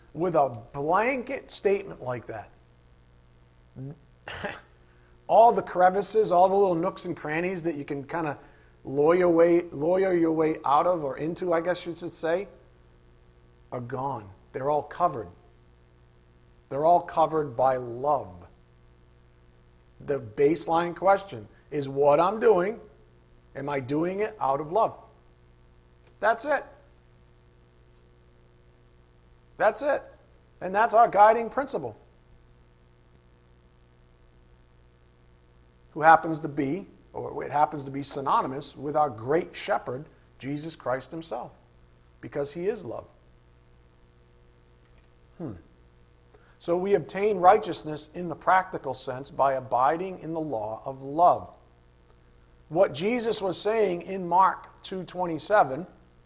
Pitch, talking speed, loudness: 125 Hz, 115 wpm, -26 LUFS